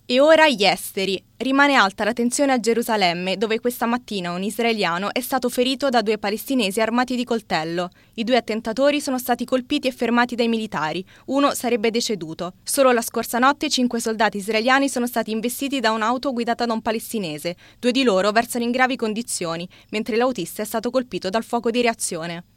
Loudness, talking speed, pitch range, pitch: -21 LUFS, 185 wpm, 210-250 Hz, 235 Hz